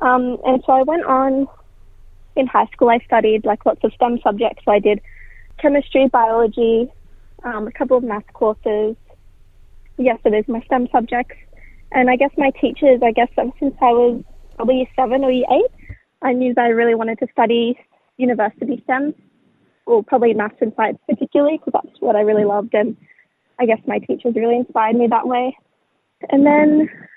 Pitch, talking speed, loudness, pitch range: 245 Hz, 190 wpm, -17 LUFS, 230-265 Hz